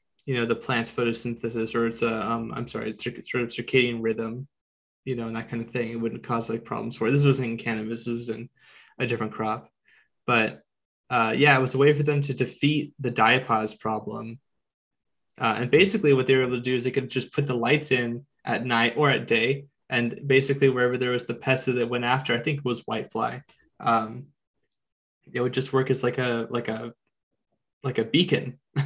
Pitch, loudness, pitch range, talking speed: 120 Hz, -25 LUFS, 115-130 Hz, 220 wpm